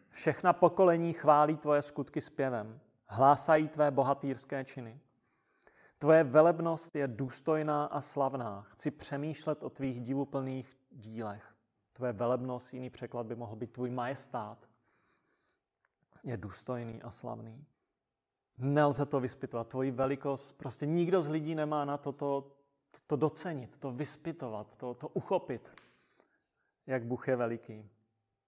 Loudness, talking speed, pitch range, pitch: -33 LUFS, 125 wpm, 120-150 Hz, 135 Hz